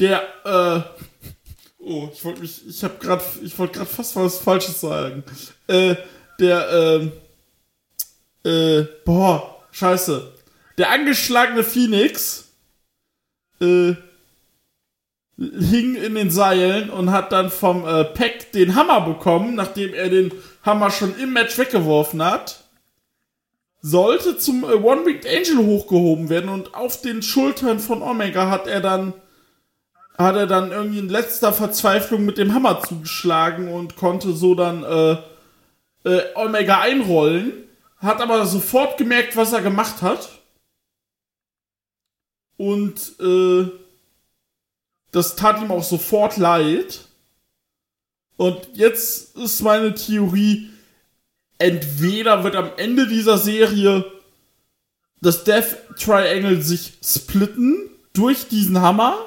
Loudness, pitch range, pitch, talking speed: -18 LUFS, 175-220 Hz, 190 Hz, 120 wpm